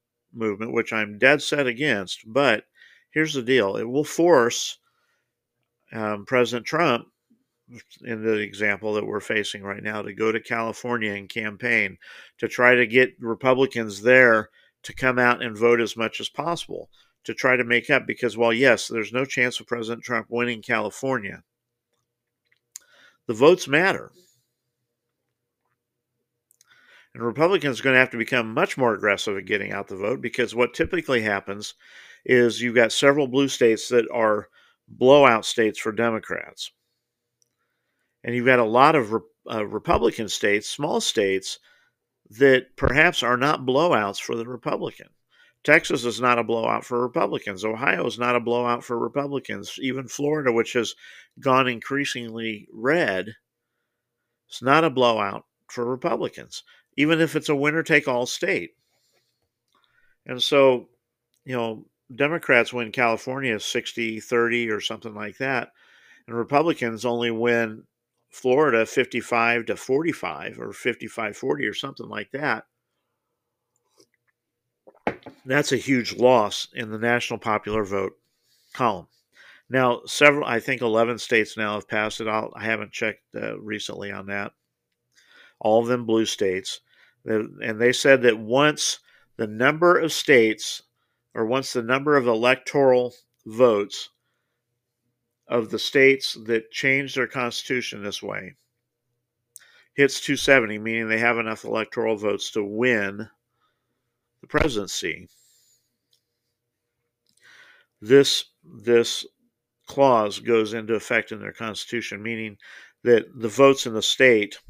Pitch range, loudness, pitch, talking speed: 110-130 Hz, -22 LUFS, 120 Hz, 140 wpm